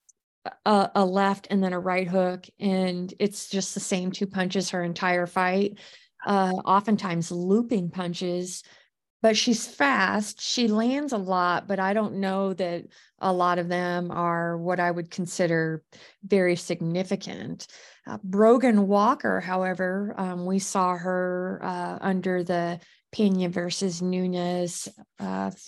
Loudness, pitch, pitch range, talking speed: -25 LUFS, 185 Hz, 180-200 Hz, 140 wpm